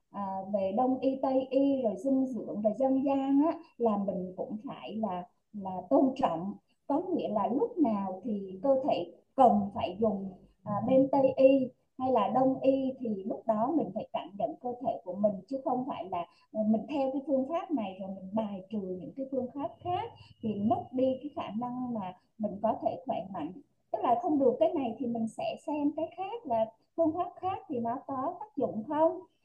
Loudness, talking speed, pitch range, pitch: -31 LUFS, 210 wpm, 220-295 Hz, 255 Hz